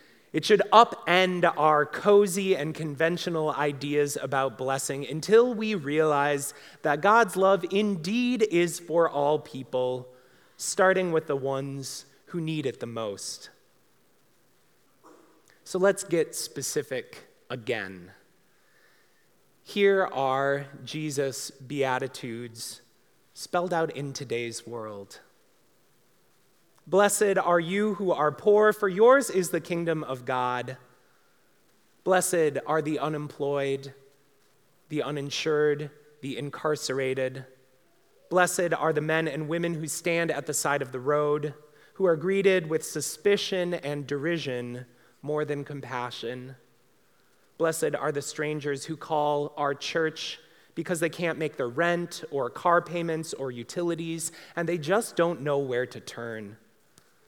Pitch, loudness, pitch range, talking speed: 155 Hz, -27 LUFS, 140-175 Hz, 120 wpm